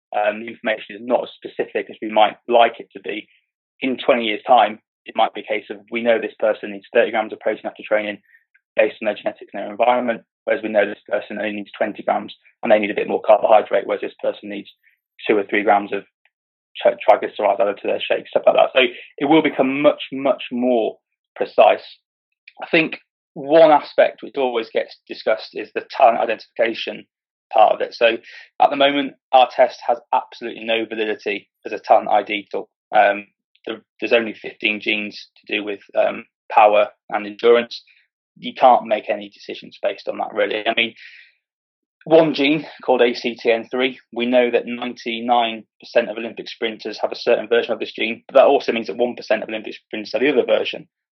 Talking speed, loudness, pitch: 200 wpm, -19 LUFS, 120 Hz